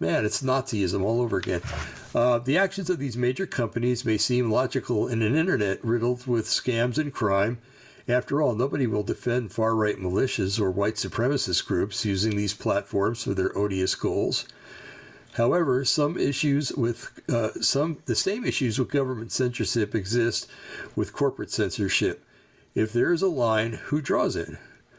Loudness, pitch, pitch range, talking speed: -25 LUFS, 120 Hz, 110-135 Hz, 160 wpm